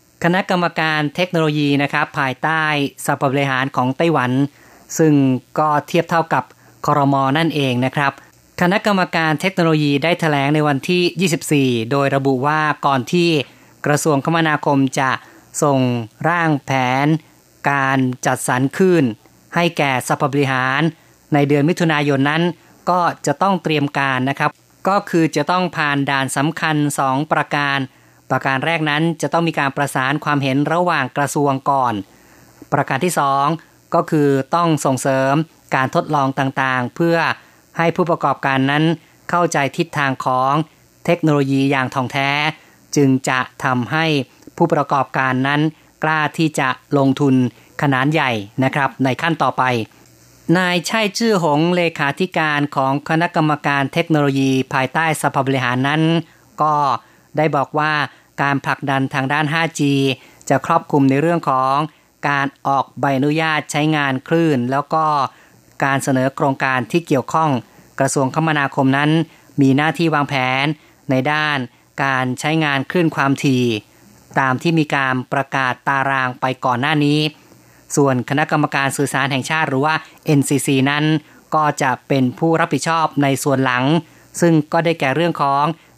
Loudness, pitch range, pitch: -17 LUFS, 135-160 Hz, 145 Hz